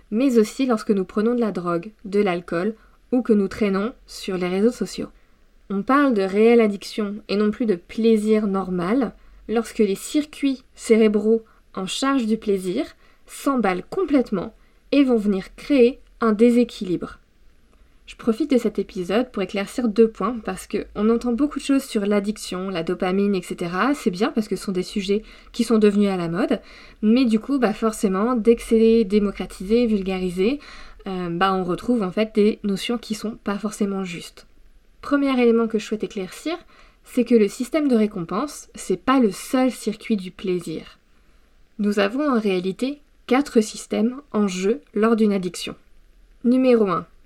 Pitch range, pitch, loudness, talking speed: 195-240 Hz, 215 Hz, -21 LUFS, 170 wpm